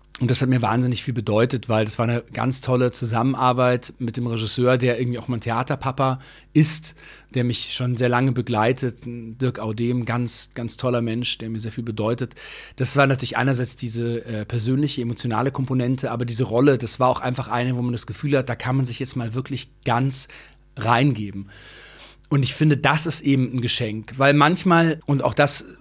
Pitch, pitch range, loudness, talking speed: 125 Hz, 120-135 Hz, -21 LUFS, 195 wpm